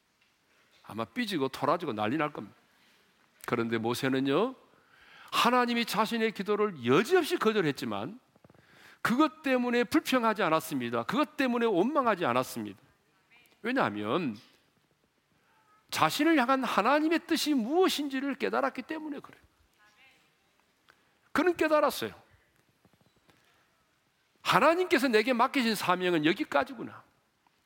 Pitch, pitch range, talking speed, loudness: 245 Hz, 195-300 Hz, 270 characters per minute, -28 LUFS